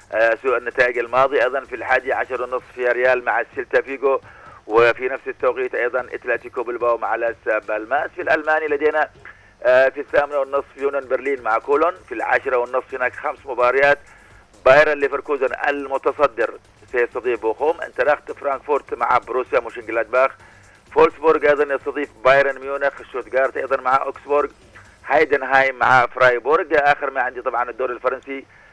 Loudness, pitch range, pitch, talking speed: -19 LUFS, 125-145 Hz, 135 Hz, 140 wpm